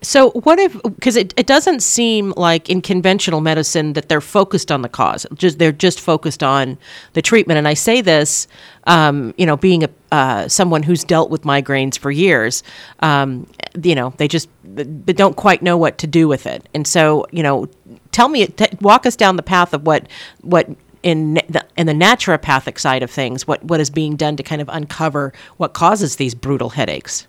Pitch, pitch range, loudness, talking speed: 160 Hz, 150-190 Hz, -15 LUFS, 205 wpm